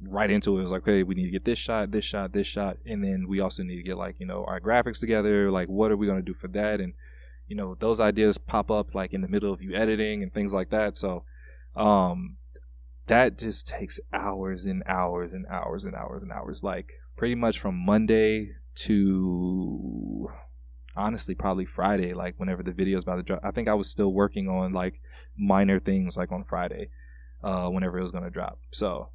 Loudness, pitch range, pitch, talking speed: -28 LUFS, 90-105 Hz, 95 Hz, 220 wpm